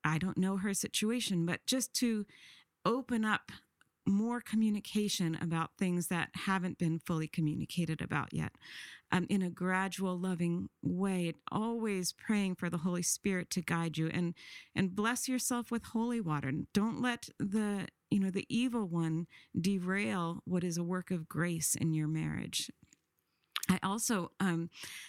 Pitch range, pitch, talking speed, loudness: 170-210 Hz, 185 Hz, 155 wpm, -35 LUFS